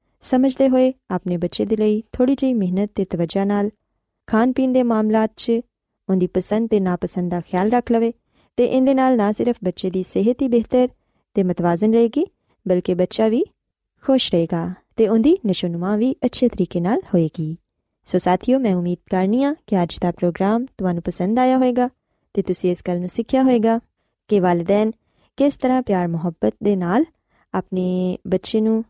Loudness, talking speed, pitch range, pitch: -20 LUFS, 170 wpm, 180-245 Hz, 210 Hz